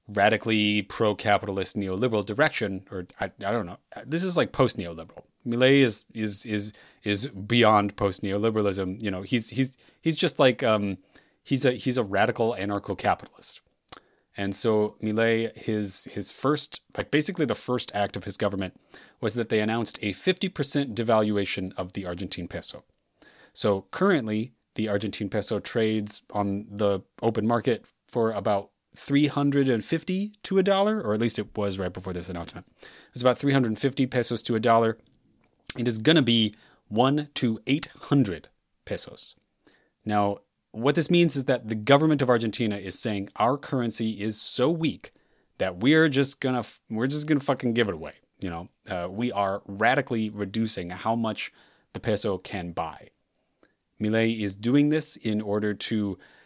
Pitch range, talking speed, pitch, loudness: 100-130 Hz, 160 wpm, 110 Hz, -26 LUFS